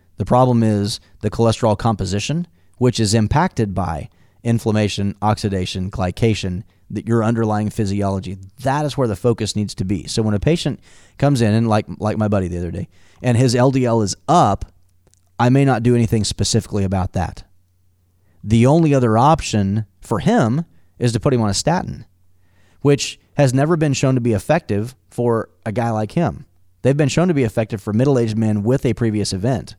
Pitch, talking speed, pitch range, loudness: 110 Hz, 185 wpm, 95-125 Hz, -18 LUFS